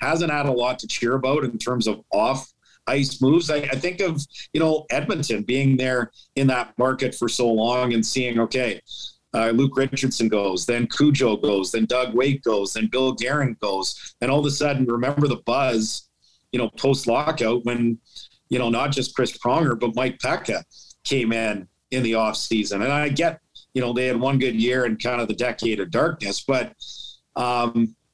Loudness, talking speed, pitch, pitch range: -22 LUFS, 200 wpm, 125 Hz, 115-135 Hz